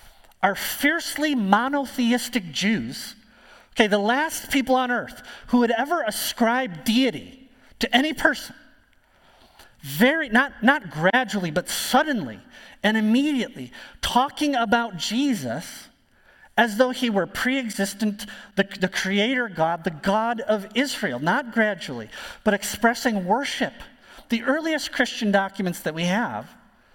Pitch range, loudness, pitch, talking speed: 205-260 Hz, -23 LUFS, 235 Hz, 120 wpm